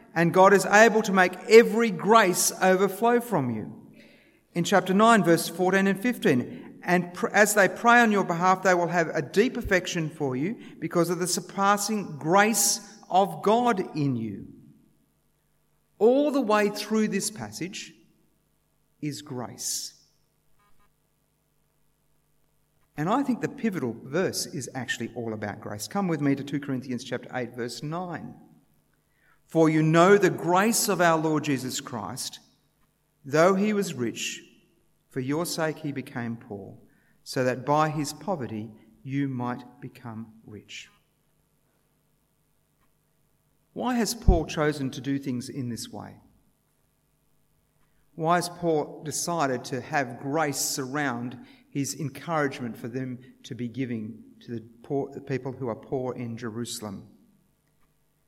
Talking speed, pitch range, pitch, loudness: 140 wpm, 130-190 Hz, 155 Hz, -25 LUFS